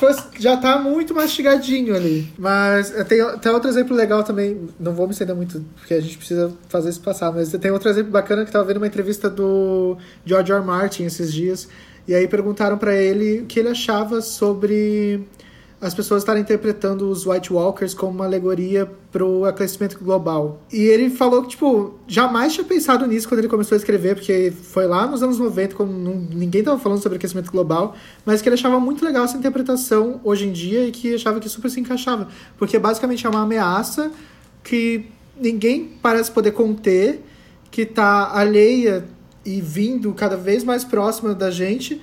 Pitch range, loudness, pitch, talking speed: 190-230 Hz, -19 LUFS, 210 Hz, 190 wpm